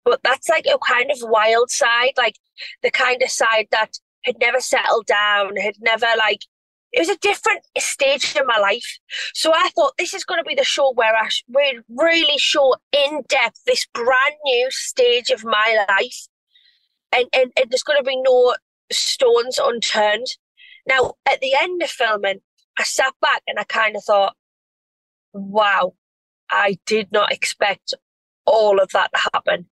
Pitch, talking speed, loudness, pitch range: 265 Hz, 175 wpm, -18 LUFS, 220-330 Hz